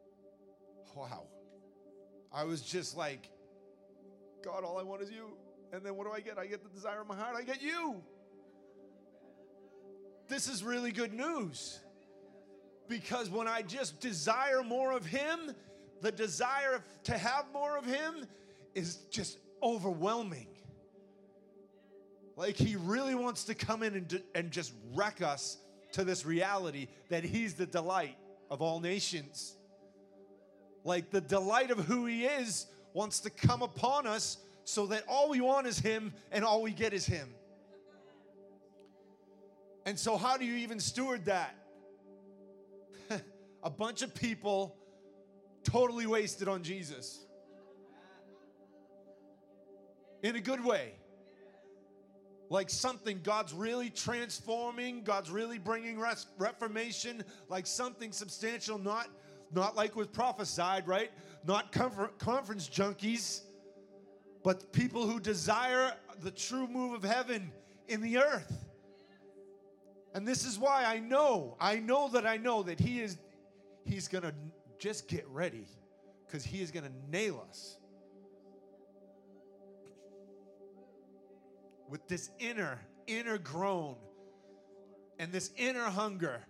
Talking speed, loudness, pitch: 130 wpm, -36 LUFS, 195 Hz